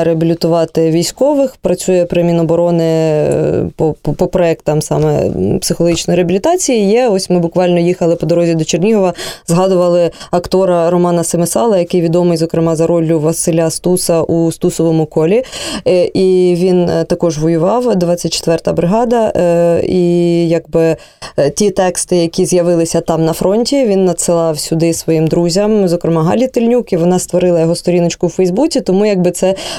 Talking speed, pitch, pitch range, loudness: 135 wpm, 175 Hz, 165-185 Hz, -12 LUFS